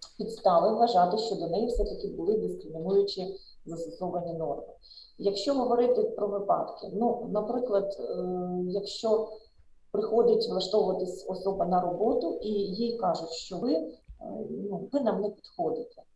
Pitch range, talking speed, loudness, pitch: 185-235 Hz, 125 wpm, -29 LUFS, 205 Hz